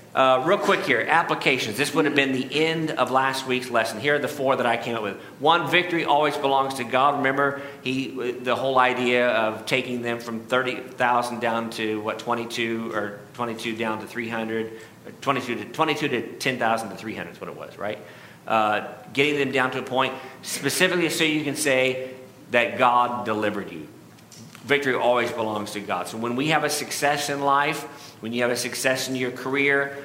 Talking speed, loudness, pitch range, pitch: 195 wpm, -23 LUFS, 115-140 Hz, 125 Hz